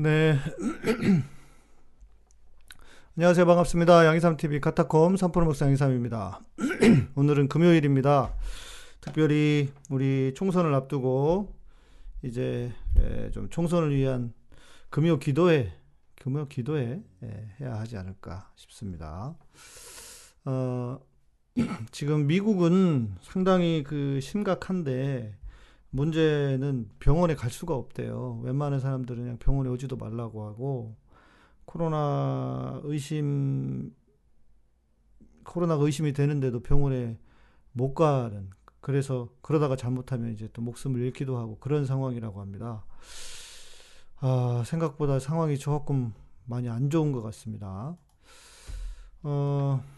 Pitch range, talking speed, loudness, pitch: 120-155 Hz, 240 characters per minute, -27 LUFS, 135 Hz